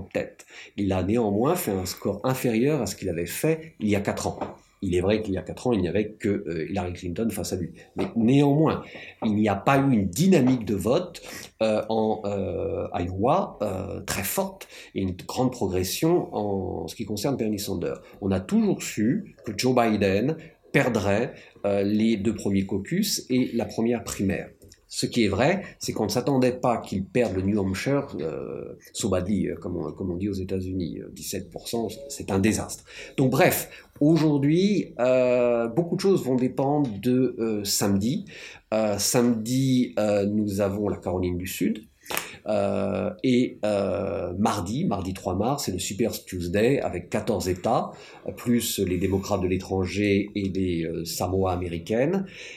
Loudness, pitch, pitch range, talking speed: -25 LUFS, 105 Hz, 95-125 Hz, 175 wpm